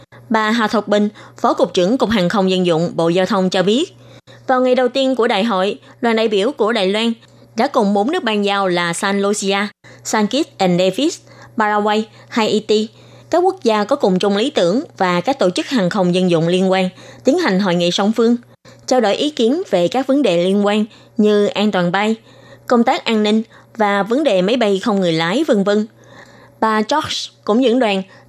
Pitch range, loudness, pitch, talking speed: 190-235 Hz, -16 LUFS, 210 Hz, 215 wpm